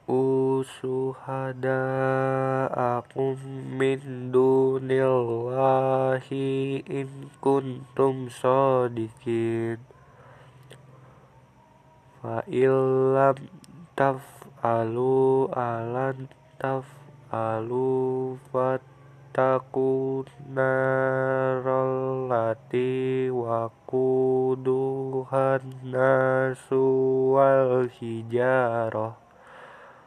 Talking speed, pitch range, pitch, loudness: 35 wpm, 130-135 Hz, 130 Hz, -25 LUFS